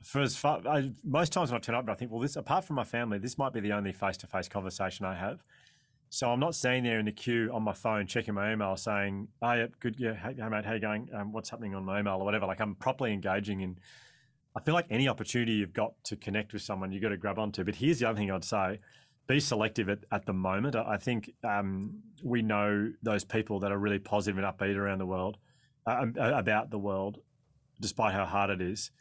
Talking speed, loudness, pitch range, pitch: 245 wpm, -32 LUFS, 100-125 Hz, 110 Hz